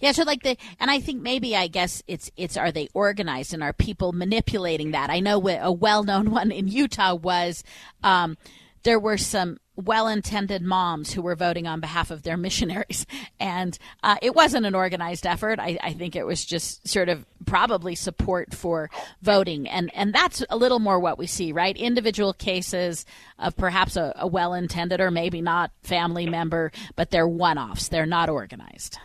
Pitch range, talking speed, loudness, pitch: 170-210 Hz, 185 wpm, -24 LUFS, 185 Hz